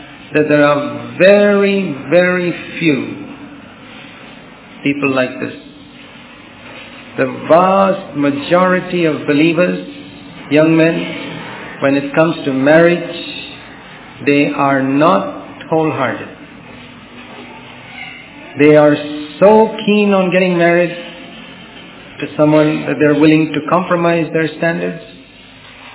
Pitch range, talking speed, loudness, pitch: 145-185 Hz, 95 wpm, -13 LUFS, 160 Hz